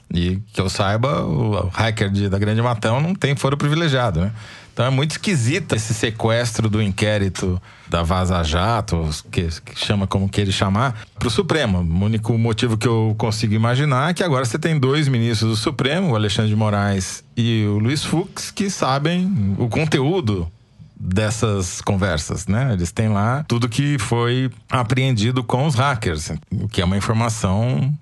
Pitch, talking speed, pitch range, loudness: 115 Hz, 175 wpm, 100-130 Hz, -20 LUFS